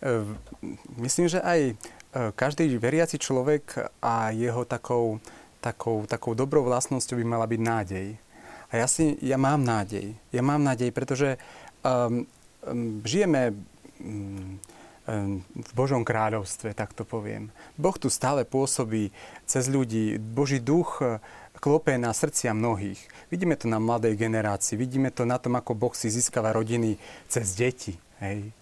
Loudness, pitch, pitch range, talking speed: -27 LUFS, 120 Hz, 110-130 Hz, 140 wpm